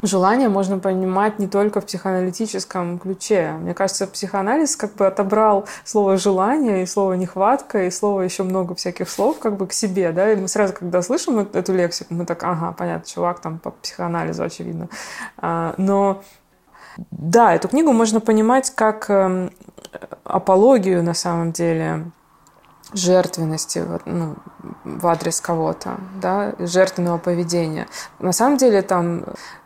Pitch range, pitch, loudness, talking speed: 175-205 Hz, 190 Hz, -19 LUFS, 140 wpm